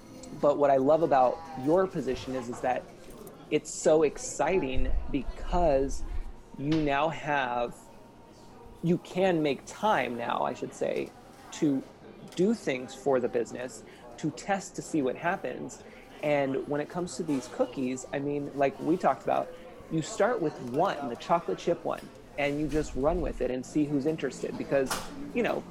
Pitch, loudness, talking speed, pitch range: 145 Hz, -30 LUFS, 165 wpm, 130-165 Hz